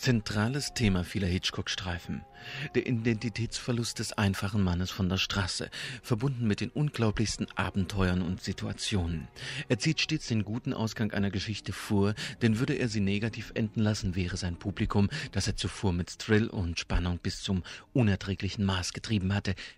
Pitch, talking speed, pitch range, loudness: 105 Hz, 155 wpm, 95-120 Hz, -31 LUFS